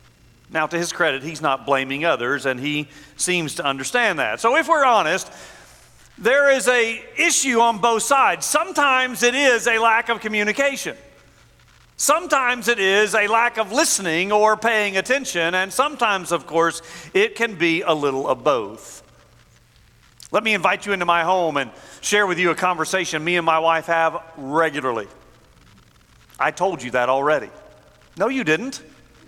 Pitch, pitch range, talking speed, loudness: 190 Hz, 160-240 Hz, 165 wpm, -19 LUFS